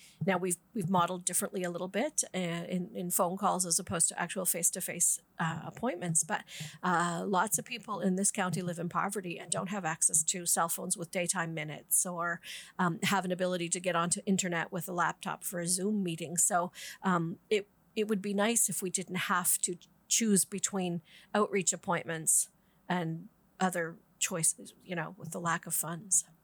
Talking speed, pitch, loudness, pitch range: 185 wpm, 180 Hz, -31 LUFS, 170-190 Hz